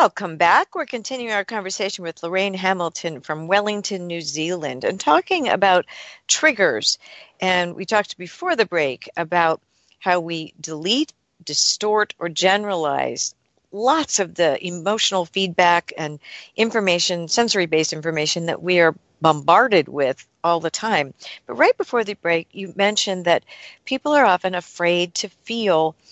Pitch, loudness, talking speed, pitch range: 180 Hz, -20 LUFS, 140 wpm, 170-210 Hz